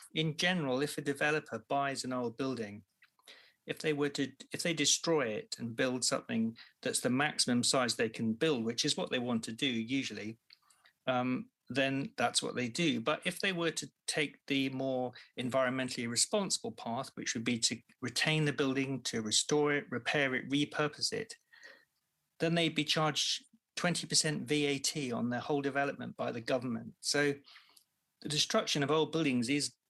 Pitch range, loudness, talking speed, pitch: 125-155 Hz, -33 LUFS, 175 wpm, 140 Hz